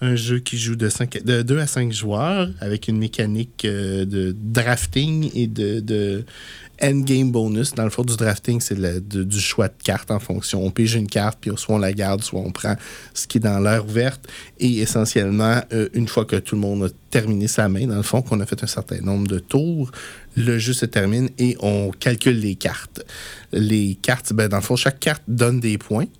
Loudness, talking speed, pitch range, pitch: -21 LUFS, 220 wpm, 100-120 Hz, 110 Hz